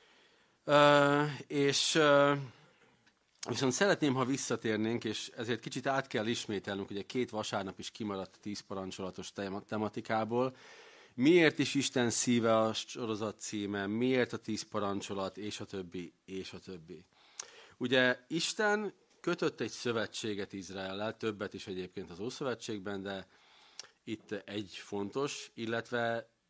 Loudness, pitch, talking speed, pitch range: -33 LUFS, 115 Hz, 125 wpm, 100-135 Hz